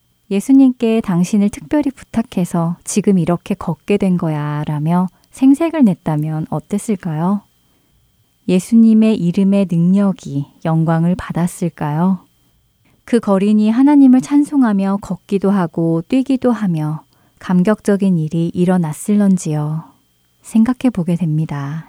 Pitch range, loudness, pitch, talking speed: 165-215 Hz, -15 LUFS, 185 Hz, 270 characters per minute